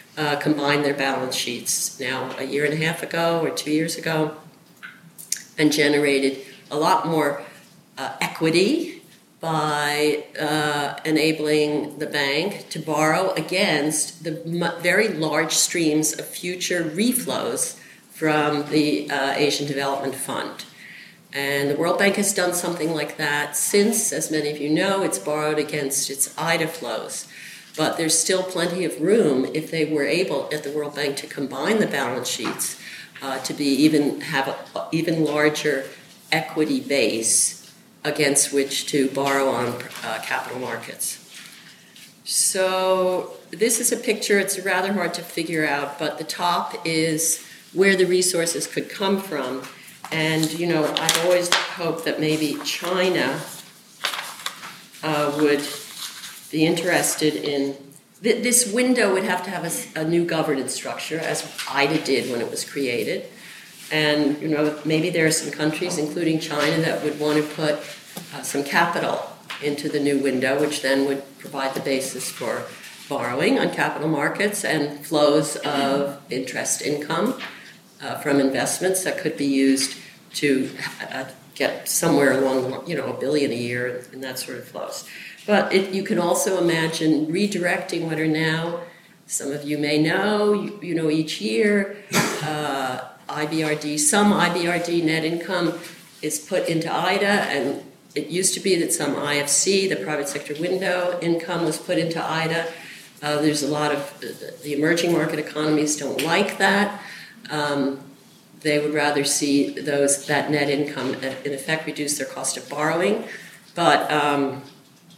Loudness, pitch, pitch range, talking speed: -22 LUFS, 155 Hz, 145-175 Hz, 155 wpm